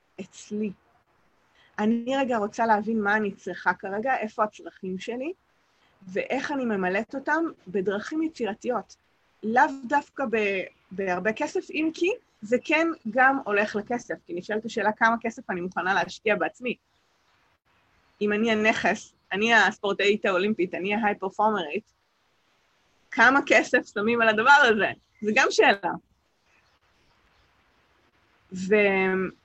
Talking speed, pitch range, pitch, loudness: 115 wpm, 200-255 Hz, 215 Hz, -25 LUFS